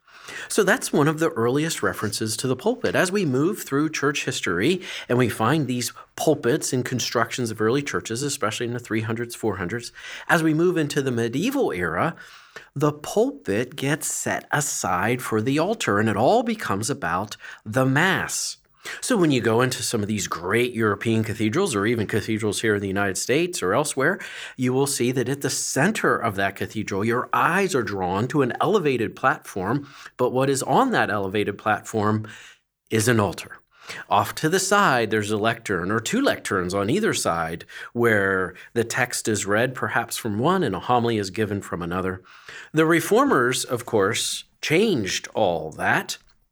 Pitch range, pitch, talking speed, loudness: 105-140 Hz, 120 Hz, 175 wpm, -23 LUFS